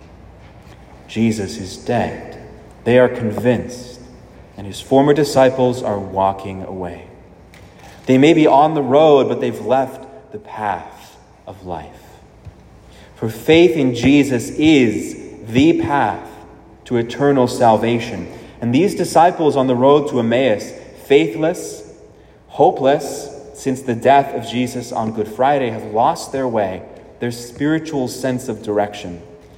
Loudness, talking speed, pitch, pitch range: -16 LUFS, 130 wpm, 125 Hz, 105-140 Hz